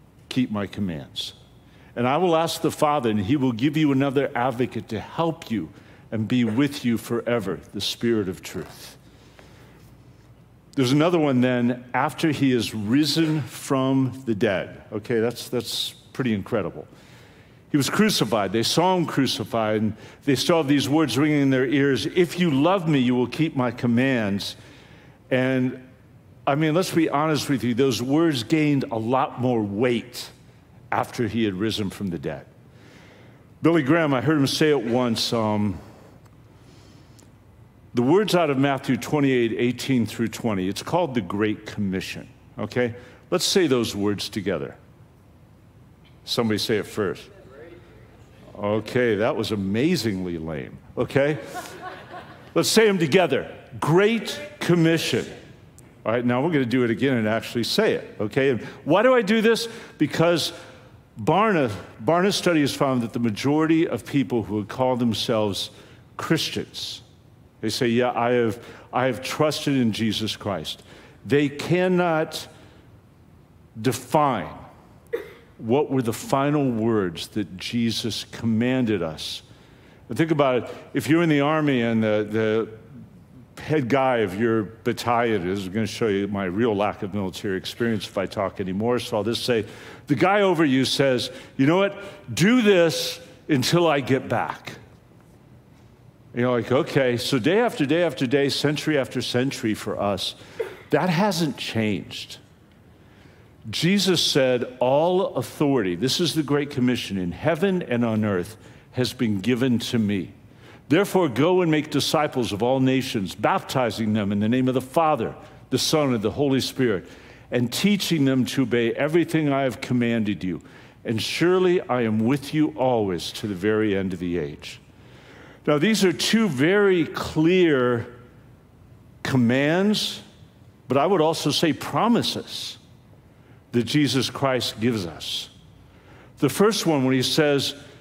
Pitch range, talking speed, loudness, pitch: 110-150 Hz, 155 wpm, -23 LUFS, 125 Hz